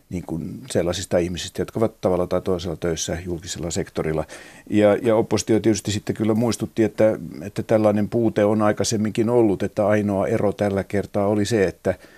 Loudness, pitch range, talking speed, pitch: -22 LUFS, 95-110 Hz, 170 wpm, 105 Hz